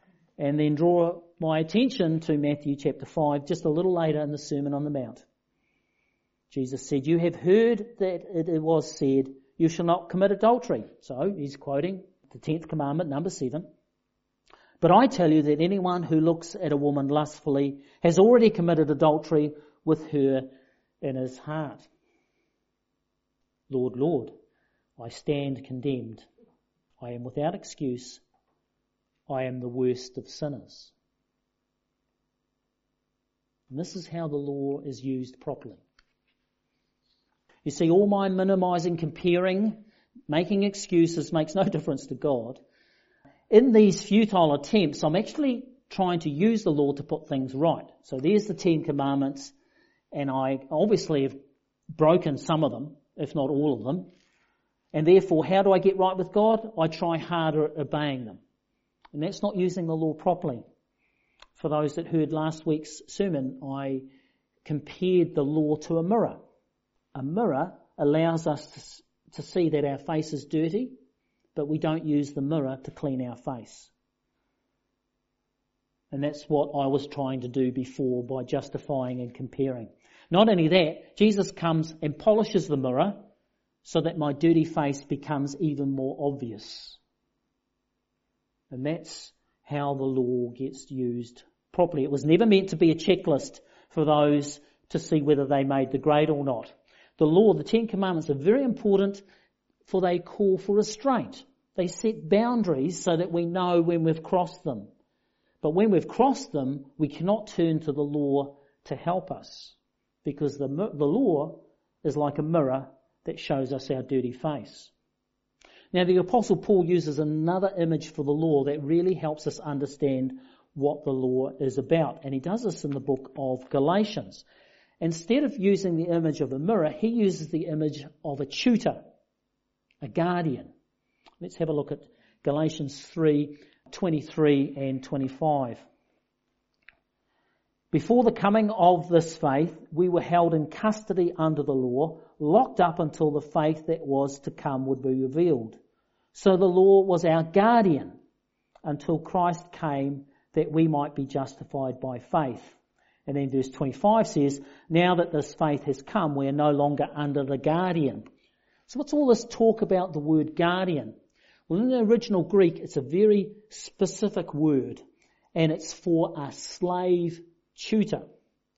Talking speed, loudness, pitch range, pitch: 155 wpm, -26 LUFS, 140-180 Hz, 155 Hz